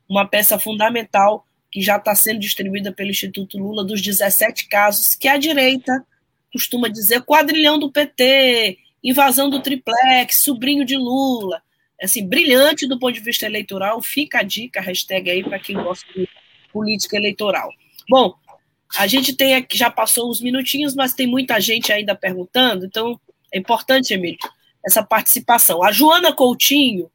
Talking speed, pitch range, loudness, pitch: 155 wpm, 200-265 Hz, -16 LUFS, 230 Hz